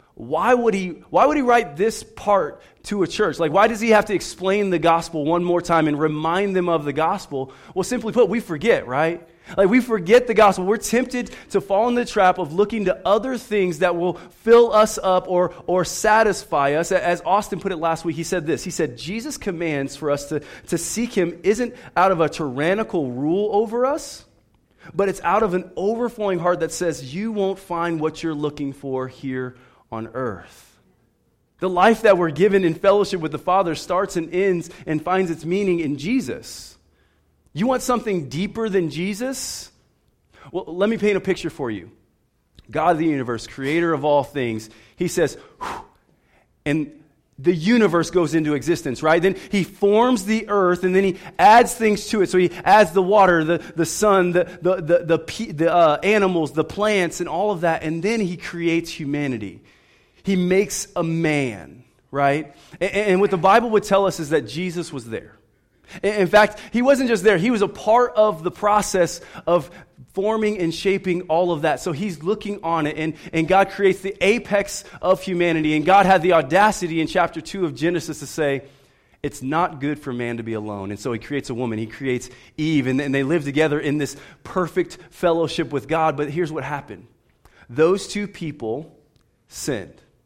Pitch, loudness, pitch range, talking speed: 175 Hz, -20 LUFS, 155-200 Hz, 195 wpm